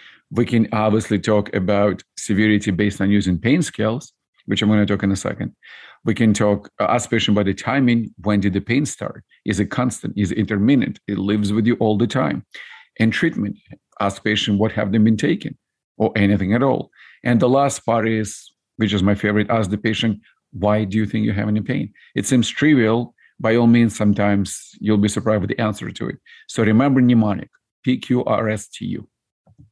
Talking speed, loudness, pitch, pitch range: 195 wpm, -19 LUFS, 110 Hz, 105-115 Hz